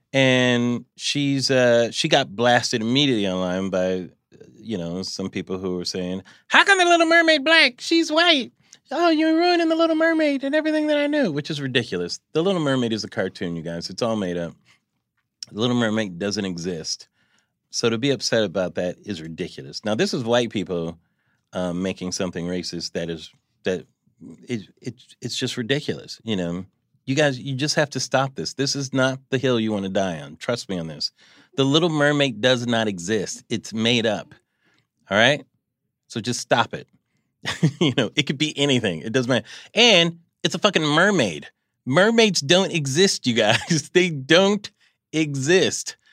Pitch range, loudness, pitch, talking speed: 95-160 Hz, -21 LUFS, 130 Hz, 185 wpm